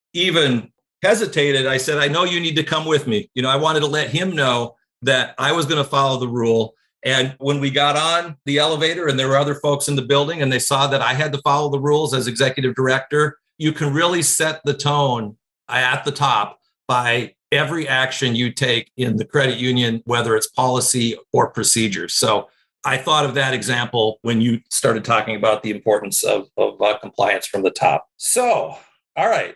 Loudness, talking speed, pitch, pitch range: -18 LUFS, 205 wpm, 140 Hz, 125-150 Hz